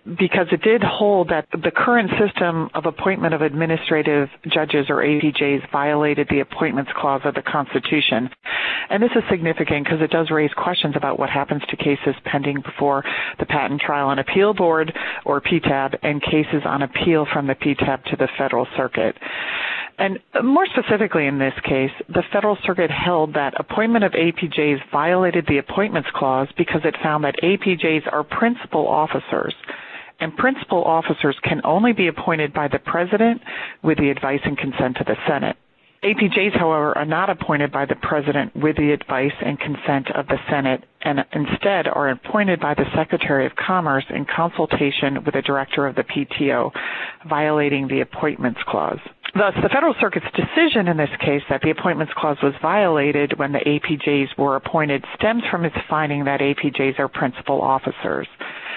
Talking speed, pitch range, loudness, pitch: 170 wpm, 140-175 Hz, -20 LUFS, 155 Hz